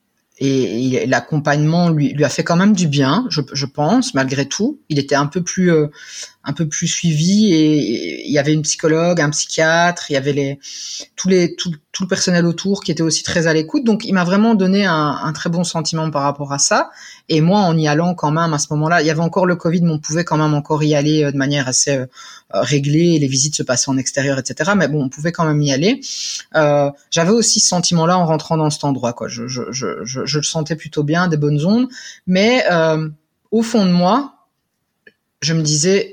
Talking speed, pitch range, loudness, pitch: 235 wpm, 145-175 Hz, -16 LUFS, 160 Hz